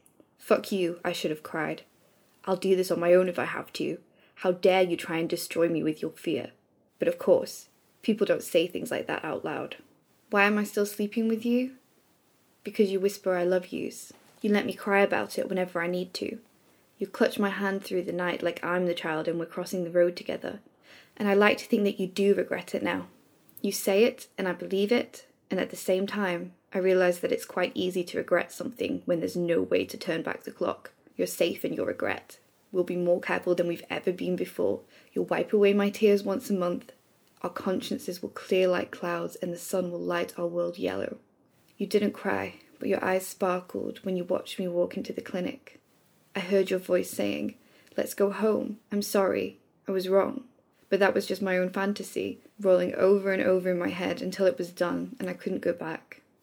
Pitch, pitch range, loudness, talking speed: 190 Hz, 180-205 Hz, -28 LUFS, 220 wpm